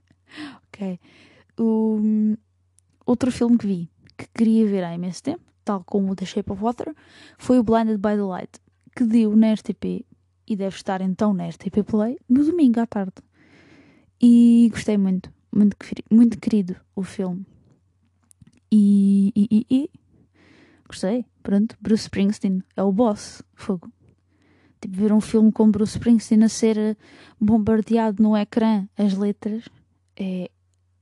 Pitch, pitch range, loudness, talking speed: 210 Hz, 190-225 Hz, -21 LUFS, 140 wpm